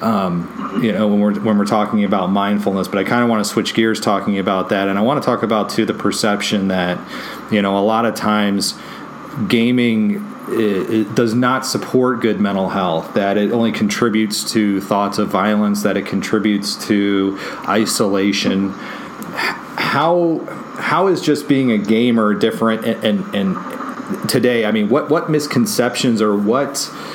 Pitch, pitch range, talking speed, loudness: 105 Hz, 100-120 Hz, 170 wpm, -17 LUFS